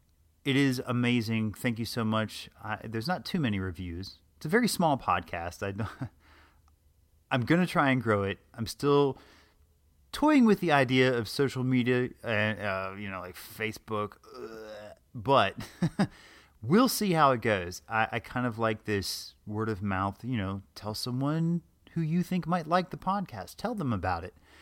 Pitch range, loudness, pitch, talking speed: 95-135 Hz, -29 LUFS, 110 Hz, 175 wpm